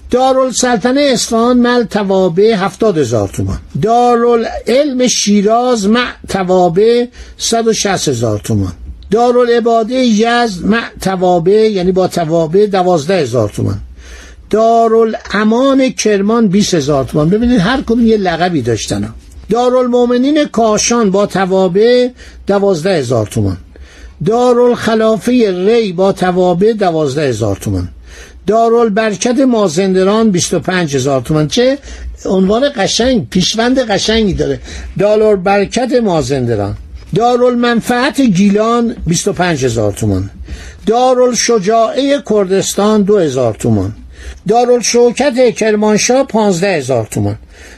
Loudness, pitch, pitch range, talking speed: -11 LUFS, 205 Hz, 155-235 Hz, 95 wpm